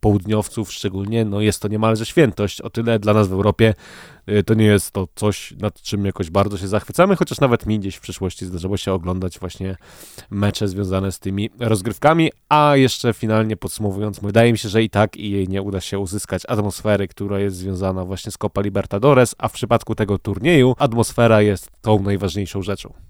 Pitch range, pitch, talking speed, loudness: 100-110 Hz, 105 Hz, 190 wpm, -19 LUFS